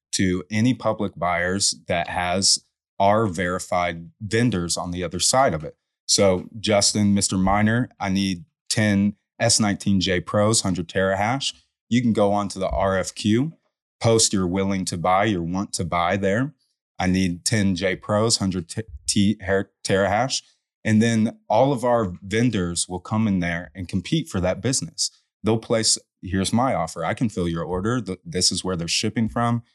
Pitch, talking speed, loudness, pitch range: 100 Hz, 165 wpm, -22 LUFS, 90-110 Hz